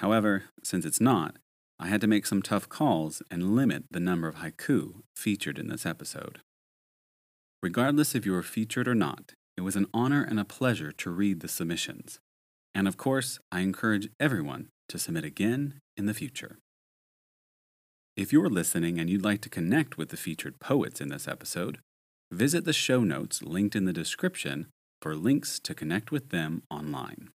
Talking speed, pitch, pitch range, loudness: 180 wpm, 105 Hz, 90-125 Hz, -29 LUFS